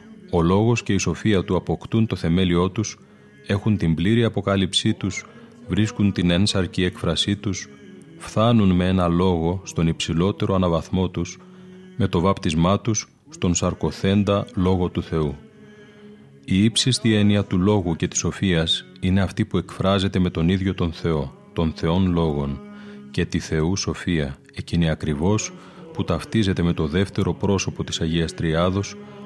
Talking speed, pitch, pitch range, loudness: 150 wpm, 90 Hz, 85-100 Hz, -22 LUFS